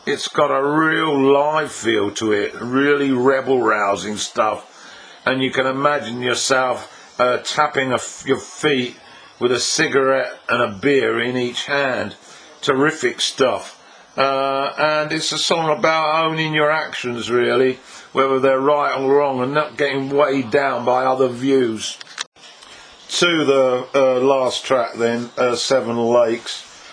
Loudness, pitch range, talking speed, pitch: -18 LUFS, 125-145 Hz, 145 wpm, 135 Hz